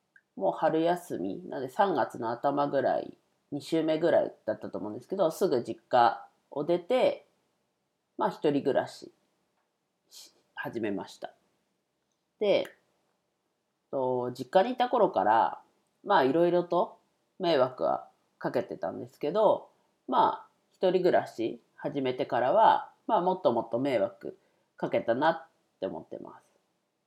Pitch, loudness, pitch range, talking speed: 170 Hz, -29 LUFS, 140-215 Hz, 245 characters per minute